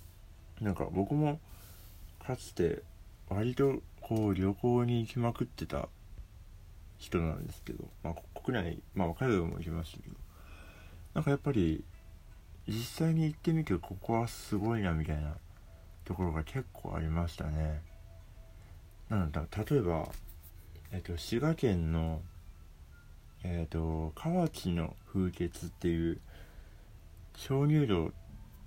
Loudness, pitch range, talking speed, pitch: -35 LUFS, 85-110 Hz, 230 characters per minute, 90 Hz